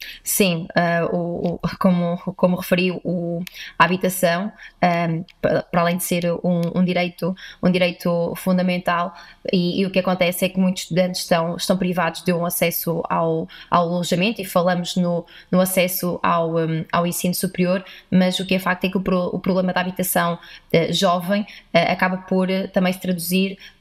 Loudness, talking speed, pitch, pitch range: -21 LUFS, 180 wpm, 180 Hz, 170-185 Hz